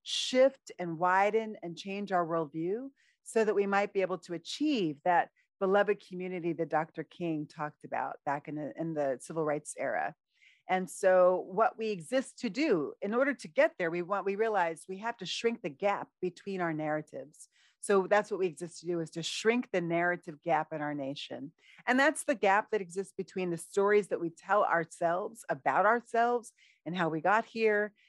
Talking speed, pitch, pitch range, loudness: 195 wpm, 185 Hz, 165-215 Hz, -31 LUFS